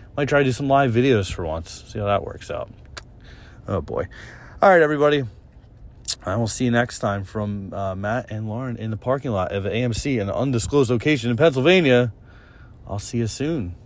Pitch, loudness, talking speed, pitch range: 115 Hz, -21 LUFS, 195 wpm, 100-130 Hz